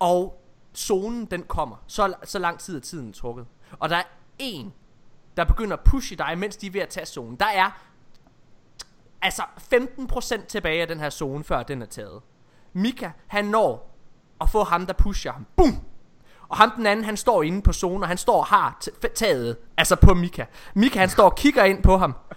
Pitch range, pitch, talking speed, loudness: 155-210 Hz, 180 Hz, 210 wpm, -23 LUFS